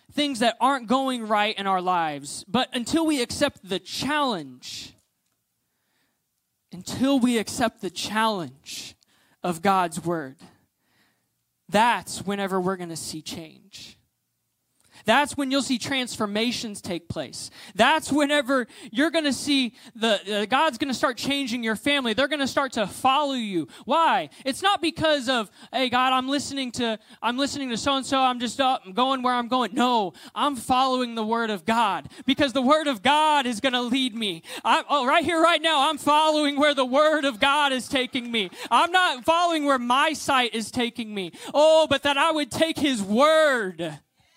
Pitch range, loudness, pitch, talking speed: 220-285 Hz, -23 LUFS, 260 Hz, 180 wpm